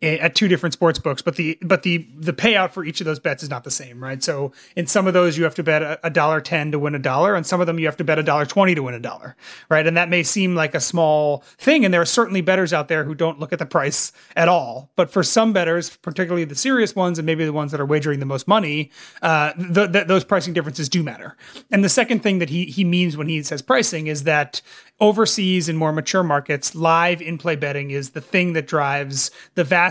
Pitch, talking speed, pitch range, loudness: 165 Hz, 260 wpm, 150-185 Hz, -19 LUFS